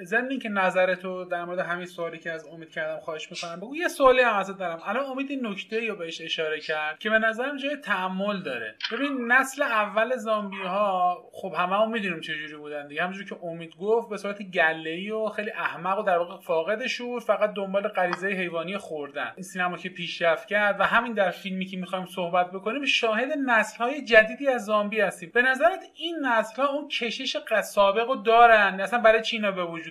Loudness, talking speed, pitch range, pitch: -25 LUFS, 200 wpm, 180-230 Hz, 200 Hz